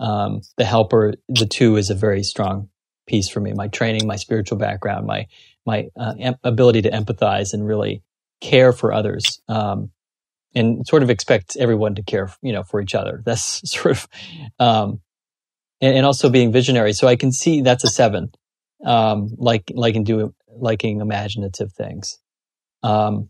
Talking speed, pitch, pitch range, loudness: 175 wpm, 110 Hz, 105-120 Hz, -18 LUFS